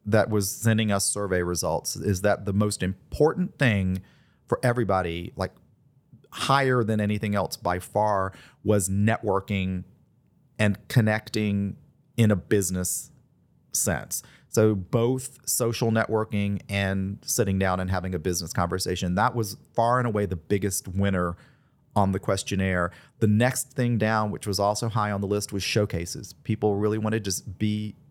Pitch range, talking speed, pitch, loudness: 95-115 Hz, 150 wpm, 105 Hz, -26 LUFS